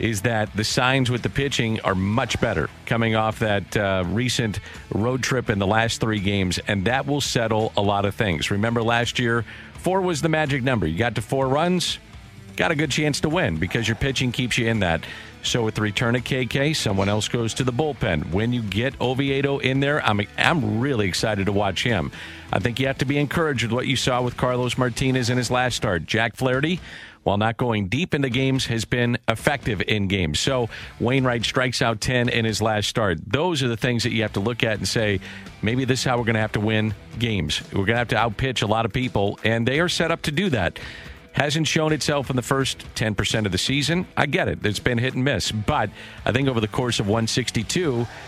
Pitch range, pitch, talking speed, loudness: 105-130 Hz, 120 Hz, 235 wpm, -22 LUFS